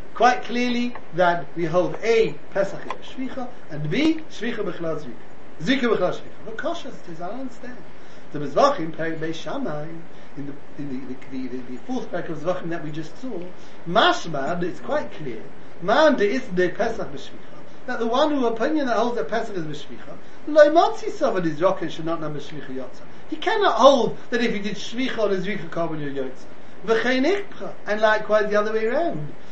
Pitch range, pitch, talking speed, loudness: 160-250 Hz, 210 Hz, 190 wpm, -23 LUFS